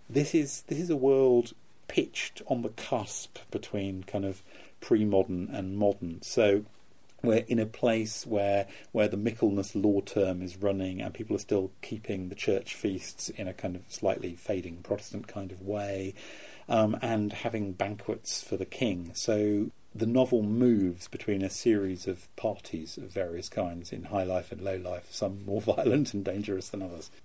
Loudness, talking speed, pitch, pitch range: -31 LUFS, 175 wpm, 100 Hz, 95-110 Hz